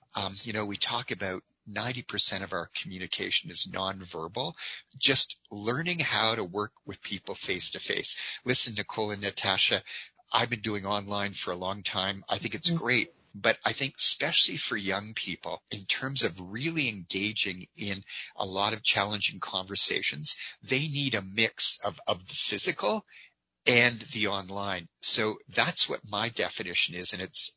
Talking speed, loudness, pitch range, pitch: 165 wpm, -26 LUFS, 95-120 Hz, 105 Hz